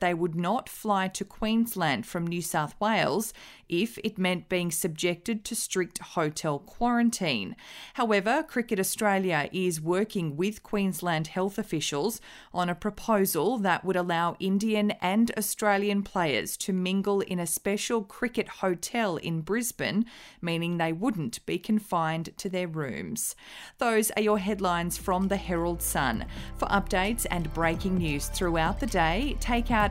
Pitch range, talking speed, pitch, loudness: 175-220 Hz, 145 wpm, 195 Hz, -28 LUFS